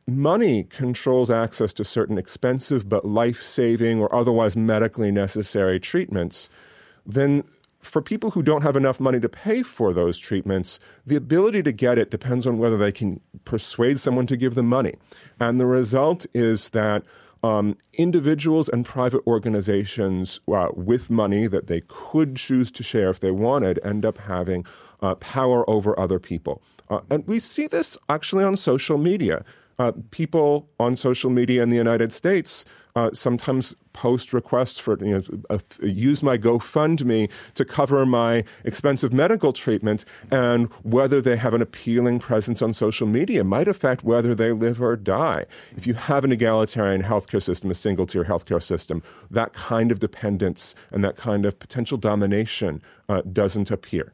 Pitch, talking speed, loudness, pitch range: 120 Hz, 170 wpm, -22 LUFS, 105-130 Hz